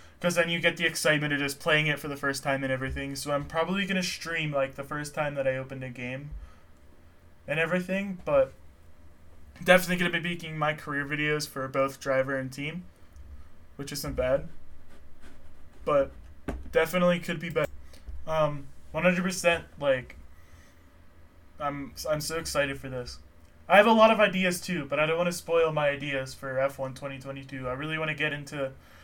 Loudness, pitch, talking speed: -28 LUFS, 140 Hz, 185 wpm